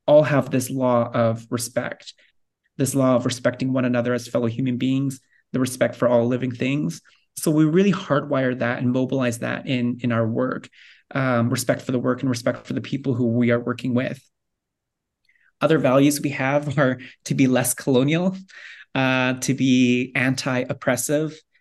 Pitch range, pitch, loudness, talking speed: 125-135 Hz, 130 Hz, -22 LUFS, 175 wpm